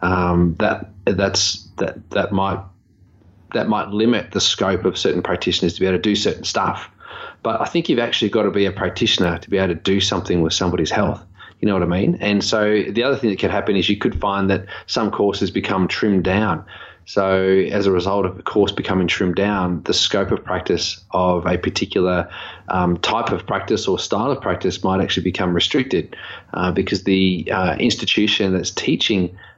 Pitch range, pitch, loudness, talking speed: 90-100 Hz, 95 Hz, -19 LUFS, 200 wpm